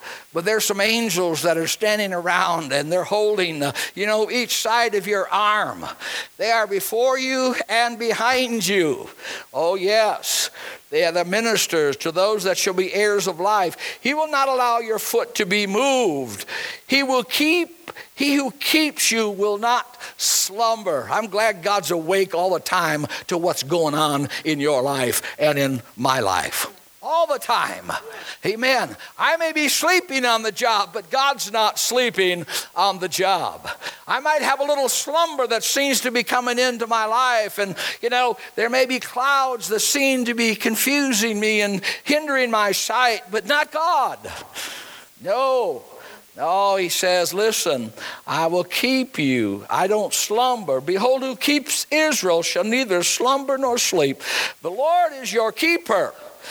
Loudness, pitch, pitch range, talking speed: -20 LUFS, 225 Hz, 195-270 Hz, 165 wpm